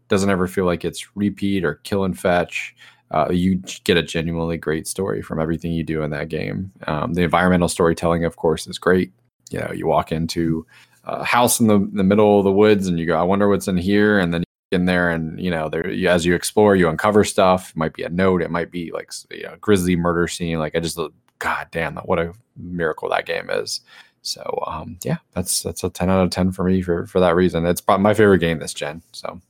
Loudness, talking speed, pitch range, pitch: -20 LUFS, 245 wpm, 85-100 Hz, 90 Hz